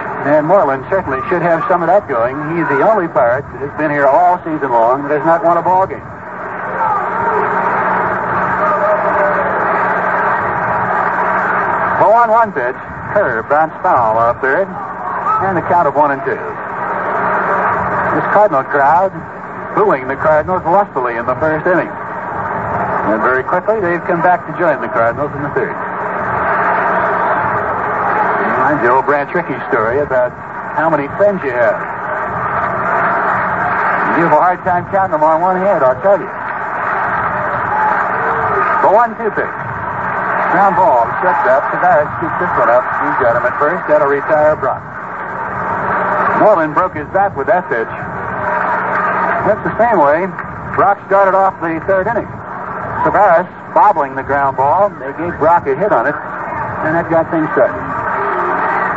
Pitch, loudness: 190 Hz, -14 LUFS